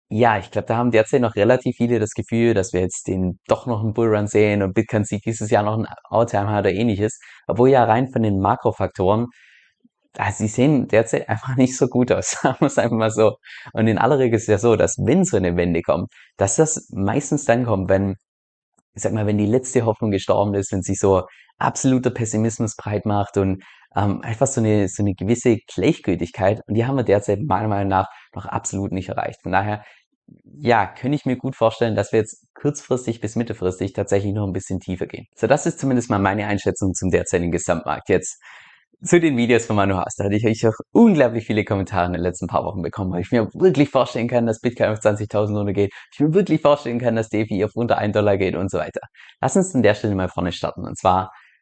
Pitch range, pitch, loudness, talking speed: 100-120 Hz, 105 Hz, -20 LUFS, 230 wpm